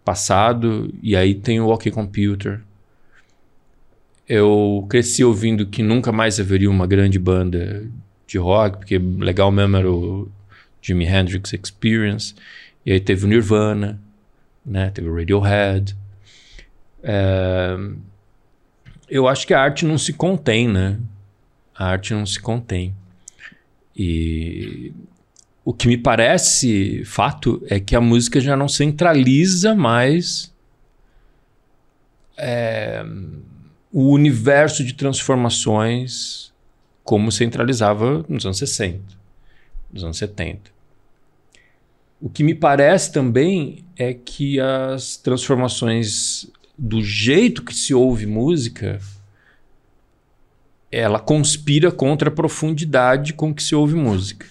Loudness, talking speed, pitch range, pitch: -18 LUFS, 115 wpm, 100-135 Hz, 115 Hz